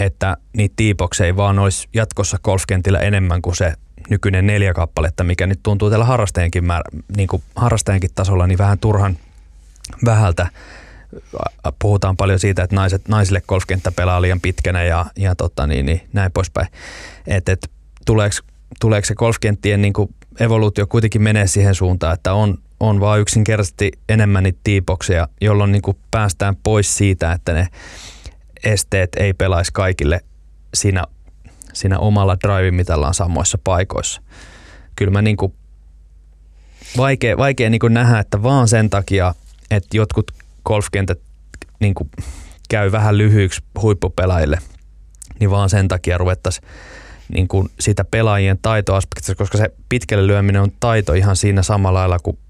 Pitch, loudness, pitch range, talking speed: 95 Hz, -17 LUFS, 85-105 Hz, 140 wpm